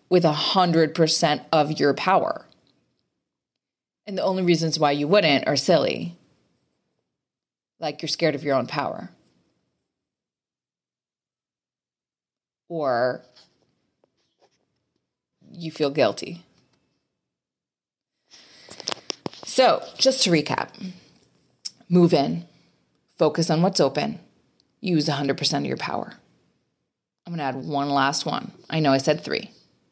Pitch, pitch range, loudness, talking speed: 160 Hz, 140-180 Hz, -22 LUFS, 100 wpm